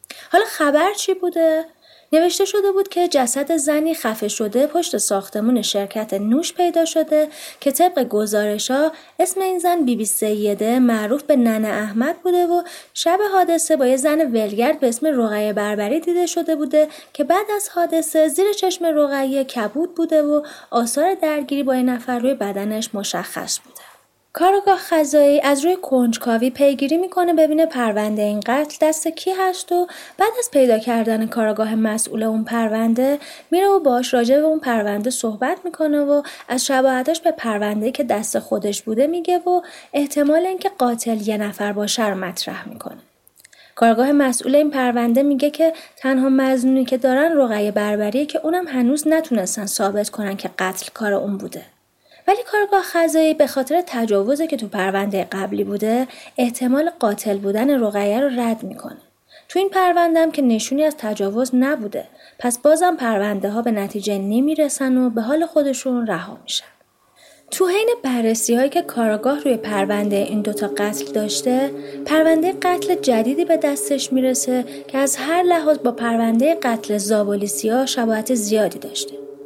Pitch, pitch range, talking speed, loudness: 265 Hz, 220-325 Hz, 160 wpm, -19 LUFS